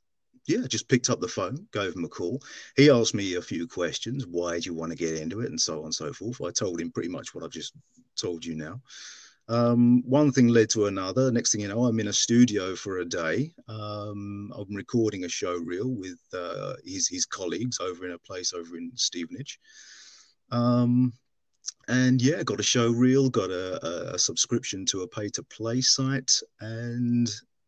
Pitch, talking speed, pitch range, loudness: 115 Hz, 200 wpm, 100-125 Hz, -26 LUFS